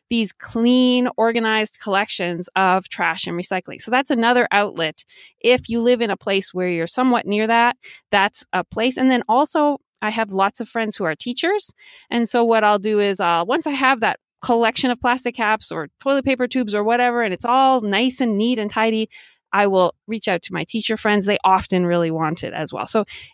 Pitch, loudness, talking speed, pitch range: 220 Hz, -19 LUFS, 210 wpm, 195-245 Hz